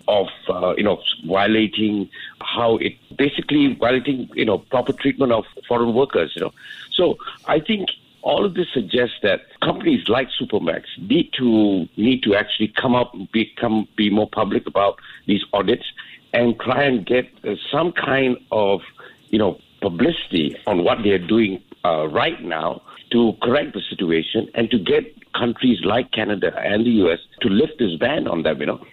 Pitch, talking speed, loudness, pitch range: 120 Hz, 170 wpm, -20 LUFS, 105-130 Hz